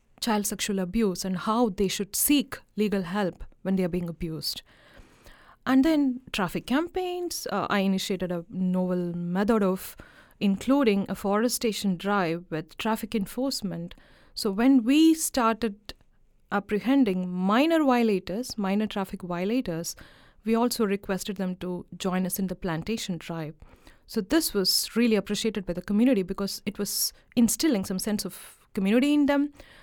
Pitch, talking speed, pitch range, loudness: 205 Hz, 145 wpm, 185-235 Hz, -26 LUFS